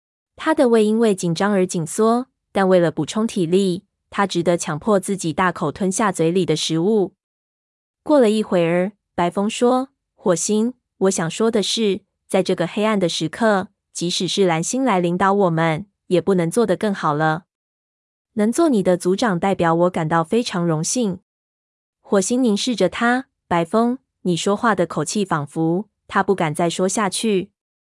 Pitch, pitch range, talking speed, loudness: 190 Hz, 170-215 Hz, 240 characters per minute, -19 LUFS